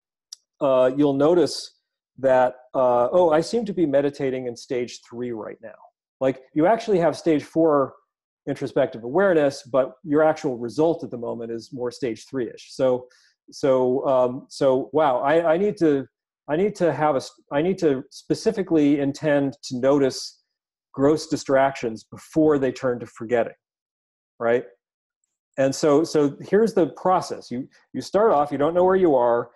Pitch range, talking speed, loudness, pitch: 125-155 Hz, 160 wpm, -22 LUFS, 140 Hz